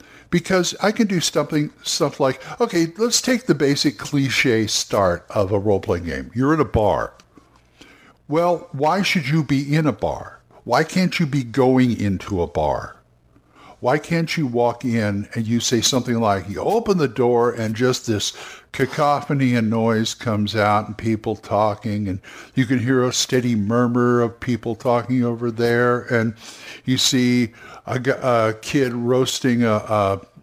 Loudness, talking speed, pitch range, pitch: -20 LUFS, 170 wpm, 115-145 Hz, 125 Hz